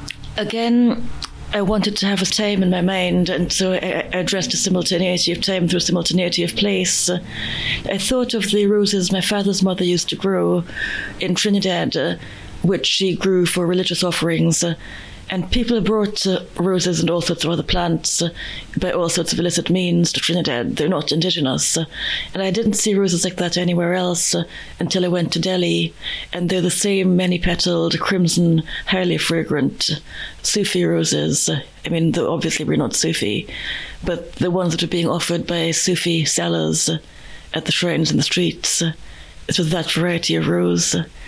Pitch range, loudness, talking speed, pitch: 165-185 Hz, -18 LUFS, 170 wpm, 175 Hz